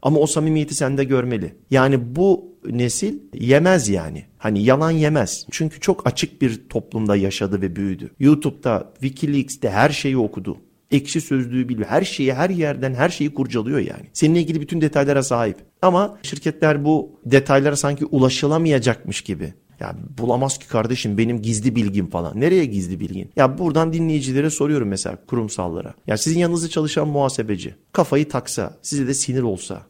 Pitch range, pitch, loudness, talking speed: 115-150 Hz, 135 Hz, -20 LUFS, 155 wpm